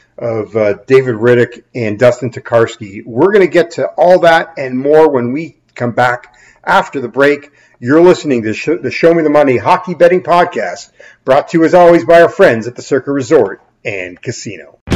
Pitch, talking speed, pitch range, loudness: 130 Hz, 195 wpm, 120-165 Hz, -11 LUFS